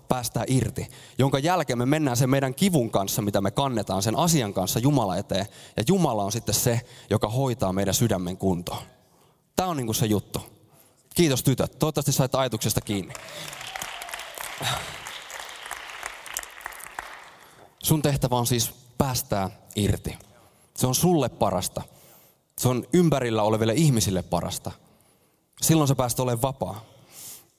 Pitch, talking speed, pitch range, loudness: 125 Hz, 130 wpm, 105-140 Hz, -25 LUFS